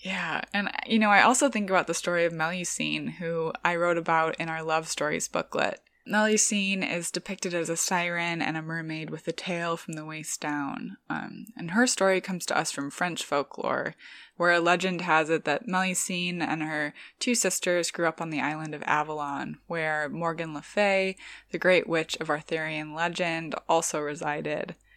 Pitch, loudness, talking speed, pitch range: 170 Hz, -27 LUFS, 185 wpm, 155-185 Hz